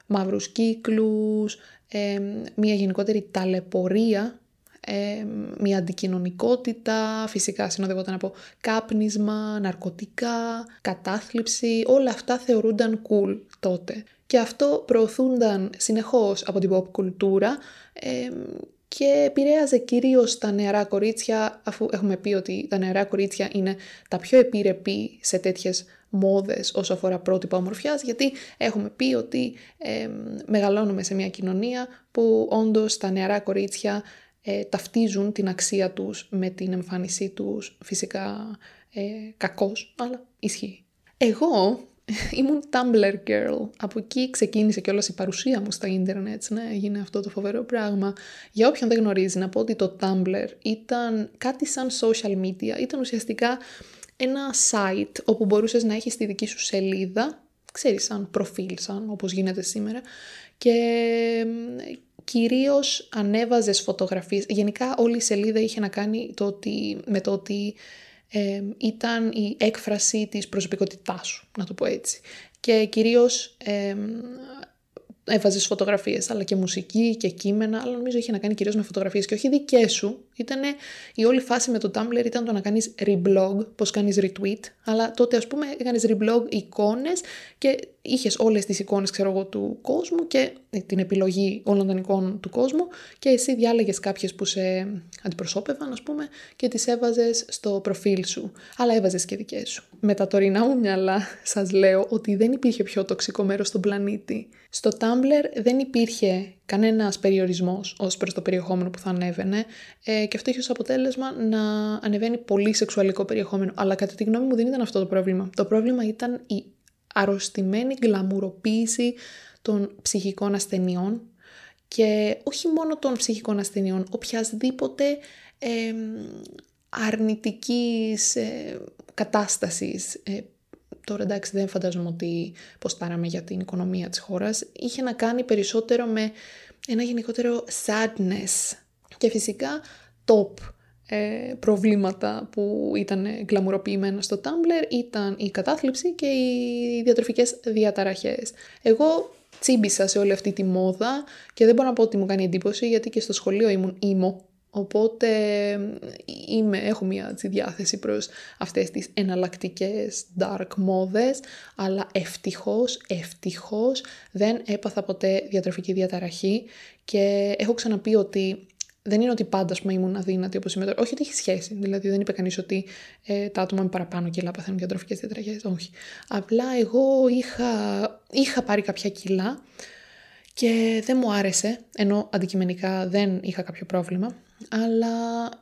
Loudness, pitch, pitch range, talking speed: -24 LUFS, 210 Hz, 195-235 Hz, 140 wpm